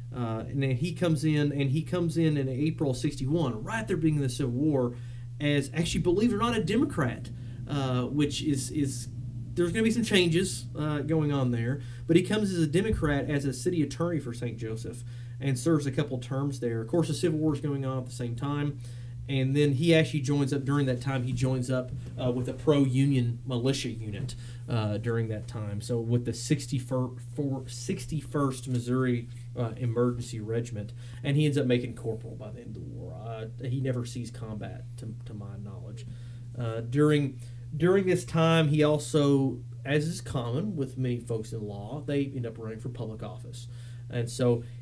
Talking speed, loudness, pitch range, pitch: 200 wpm, -29 LUFS, 120-145 Hz, 130 Hz